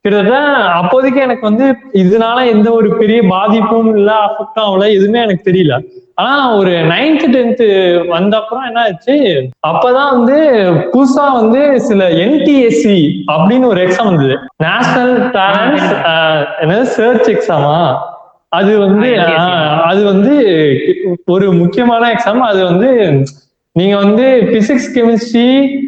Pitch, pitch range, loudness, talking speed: 220 Hz, 185-250 Hz, -10 LUFS, 110 wpm